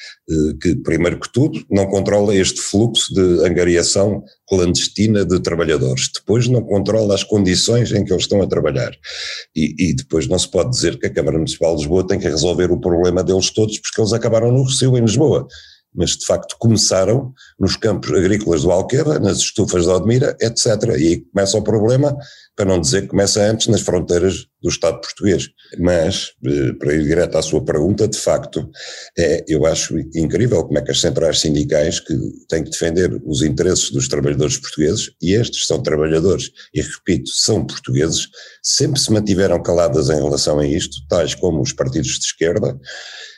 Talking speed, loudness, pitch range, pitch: 185 wpm, -16 LUFS, 90-110 Hz, 100 Hz